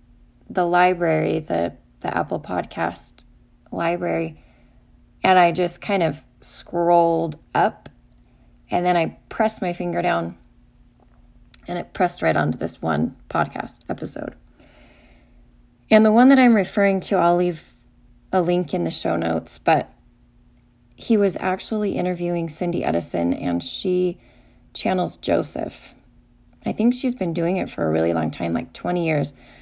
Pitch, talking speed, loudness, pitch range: 175 Hz, 140 wpm, -21 LUFS, 135-185 Hz